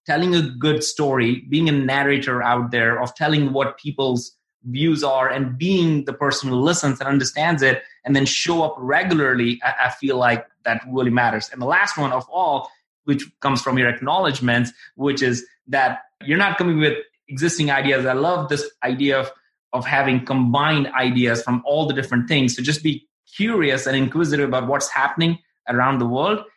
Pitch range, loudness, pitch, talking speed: 130-150 Hz, -20 LUFS, 140 Hz, 185 wpm